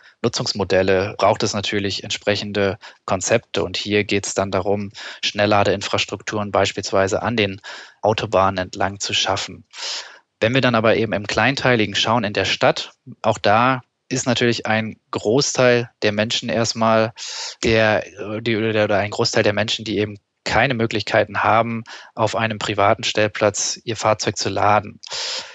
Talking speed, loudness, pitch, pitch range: 140 wpm, -19 LUFS, 105 Hz, 100-115 Hz